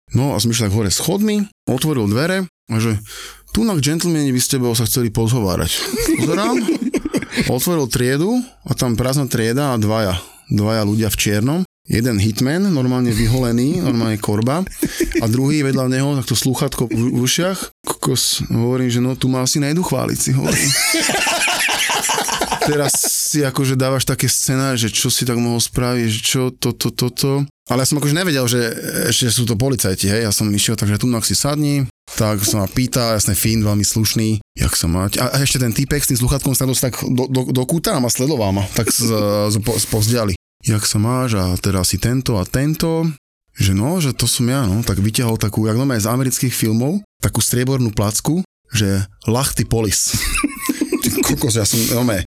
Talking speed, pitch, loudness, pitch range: 185 wpm, 125 Hz, -17 LUFS, 110-140 Hz